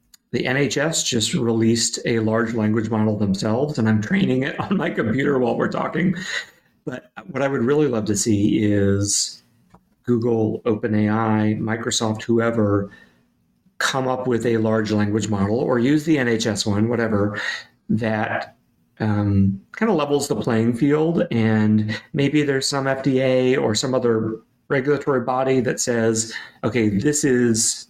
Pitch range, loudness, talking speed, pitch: 110-135 Hz, -20 LUFS, 145 wpm, 115 Hz